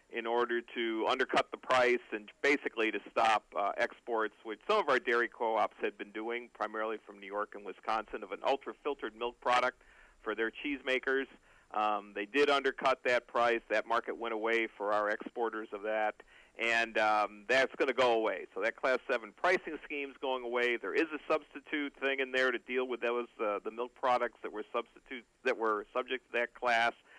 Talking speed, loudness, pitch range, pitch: 200 wpm, -33 LUFS, 110-130 Hz, 120 Hz